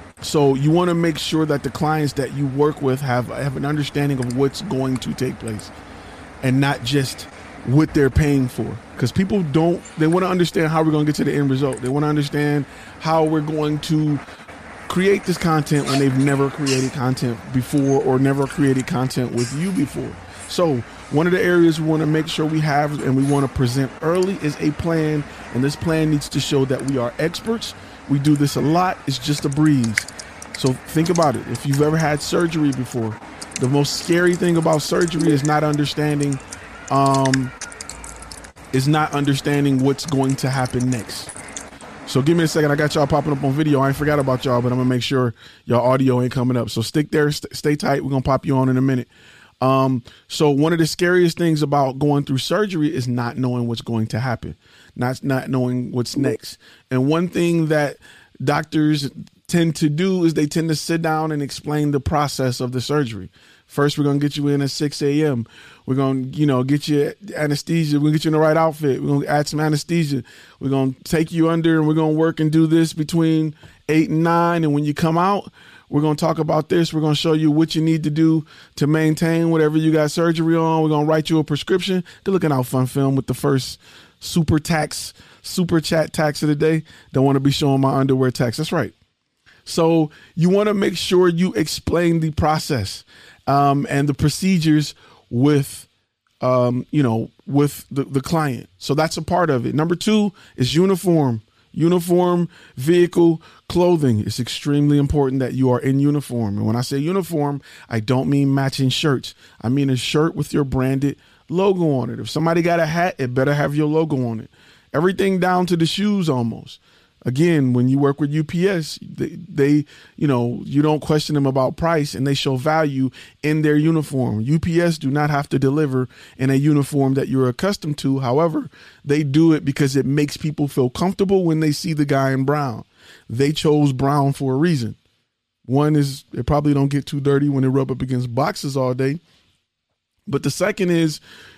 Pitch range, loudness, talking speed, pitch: 130-160 Hz, -19 LUFS, 210 wpm, 145 Hz